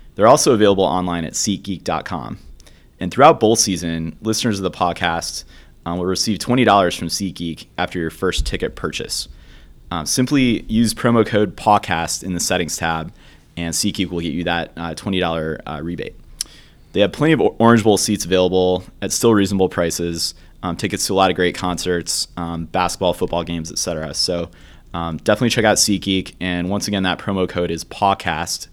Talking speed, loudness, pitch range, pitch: 180 wpm, -18 LUFS, 85-100 Hz, 90 Hz